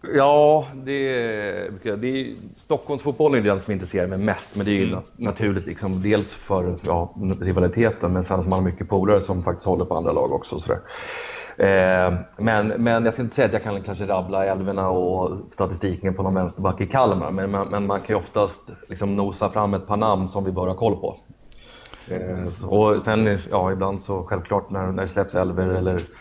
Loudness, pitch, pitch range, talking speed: -22 LUFS, 100 Hz, 95-105 Hz, 205 wpm